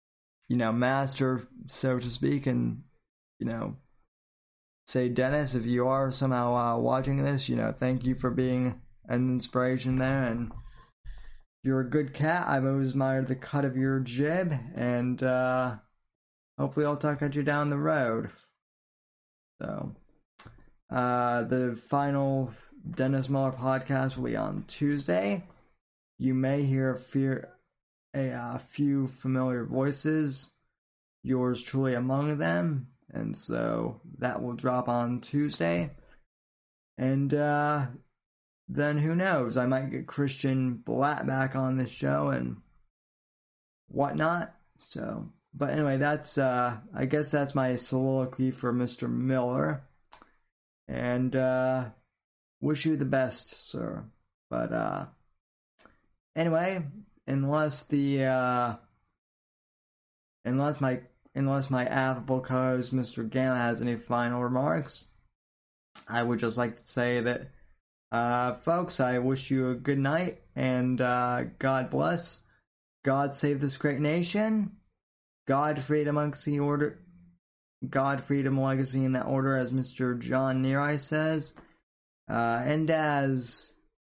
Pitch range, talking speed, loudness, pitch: 120-140 Hz, 130 wpm, -29 LUFS, 130 Hz